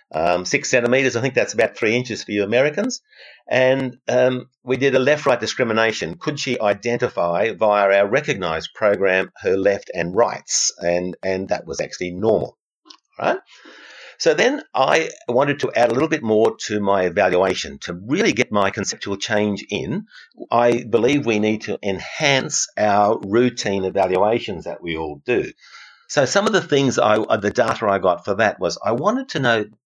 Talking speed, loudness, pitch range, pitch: 180 wpm, -19 LUFS, 100-125 Hz, 110 Hz